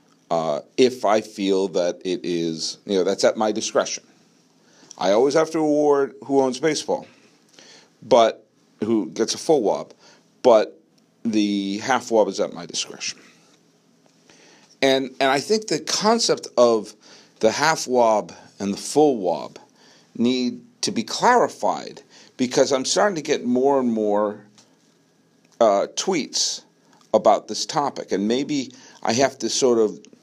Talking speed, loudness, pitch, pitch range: 145 wpm, -21 LUFS, 125 Hz, 105-150 Hz